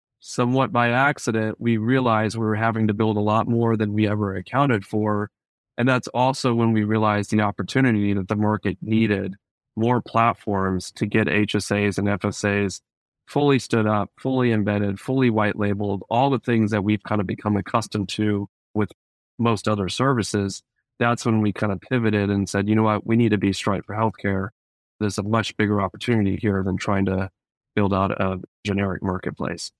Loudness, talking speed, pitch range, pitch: -22 LUFS, 185 wpm, 100-115 Hz, 105 Hz